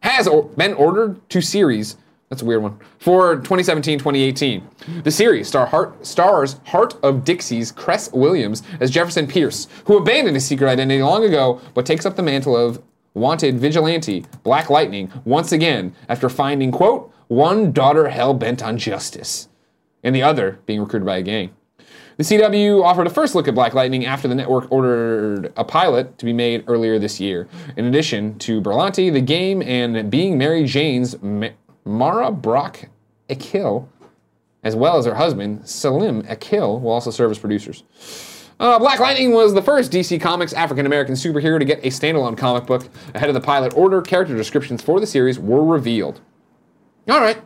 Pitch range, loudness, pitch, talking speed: 115-165 Hz, -17 LUFS, 135 Hz, 175 wpm